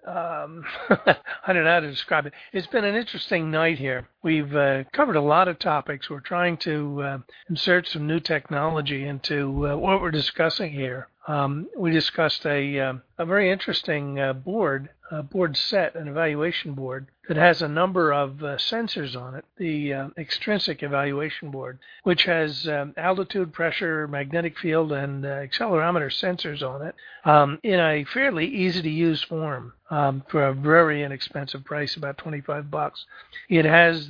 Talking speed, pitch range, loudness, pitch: 170 wpm, 140-170 Hz, -24 LUFS, 155 Hz